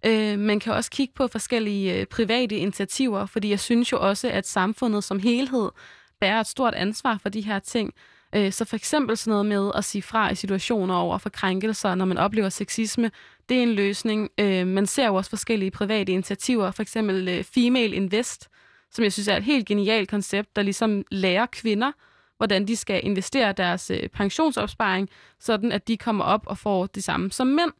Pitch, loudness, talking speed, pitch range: 210 Hz, -24 LUFS, 185 wpm, 195-230 Hz